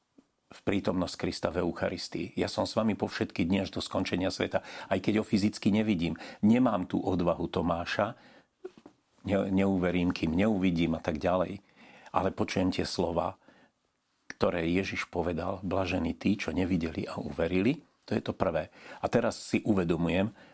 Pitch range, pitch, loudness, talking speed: 90-100 Hz, 95 Hz, -30 LUFS, 155 wpm